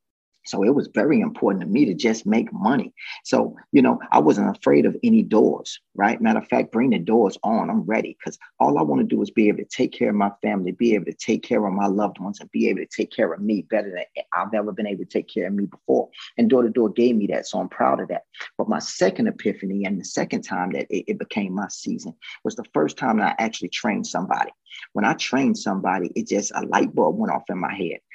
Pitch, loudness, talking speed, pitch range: 105 Hz, -22 LUFS, 260 wpm, 100-120 Hz